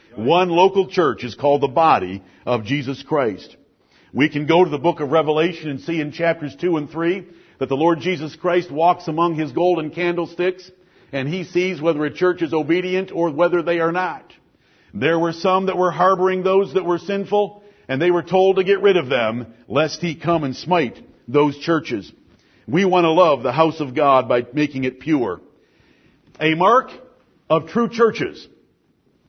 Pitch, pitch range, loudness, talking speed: 170 Hz, 150-180 Hz, -19 LUFS, 185 wpm